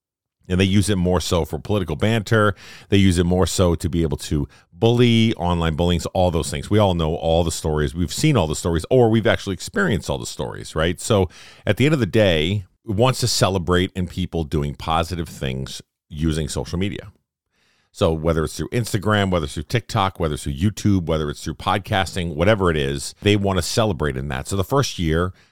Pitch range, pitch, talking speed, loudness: 80-105 Hz, 90 Hz, 220 wpm, -20 LUFS